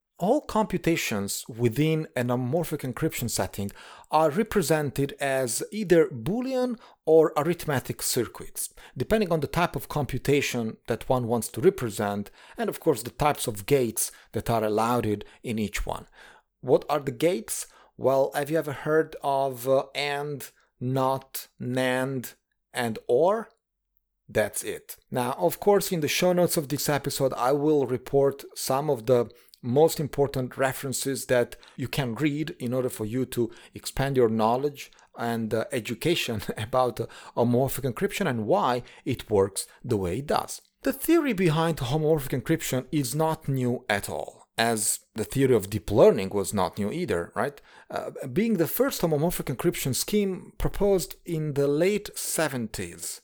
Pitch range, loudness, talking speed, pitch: 120-165 Hz, -26 LUFS, 155 wpm, 140 Hz